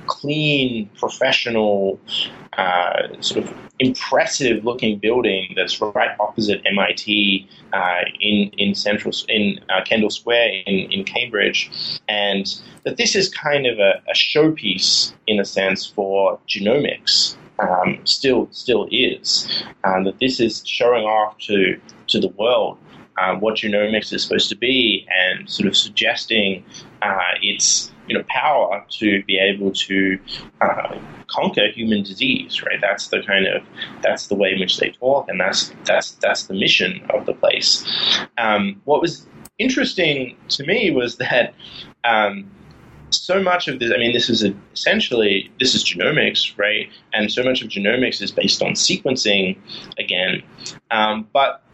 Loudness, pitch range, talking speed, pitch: -18 LUFS, 100-130 Hz, 150 wpm, 110 Hz